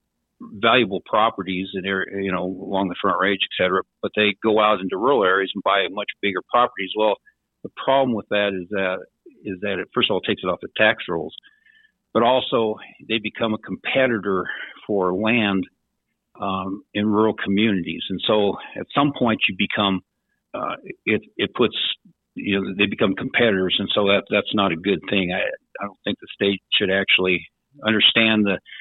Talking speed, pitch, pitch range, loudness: 180 wpm, 100 Hz, 95-110 Hz, -21 LUFS